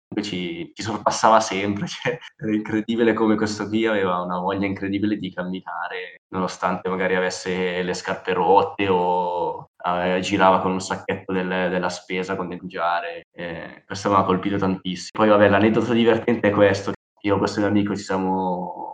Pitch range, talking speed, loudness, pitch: 90-105 Hz, 170 wpm, -22 LUFS, 95 Hz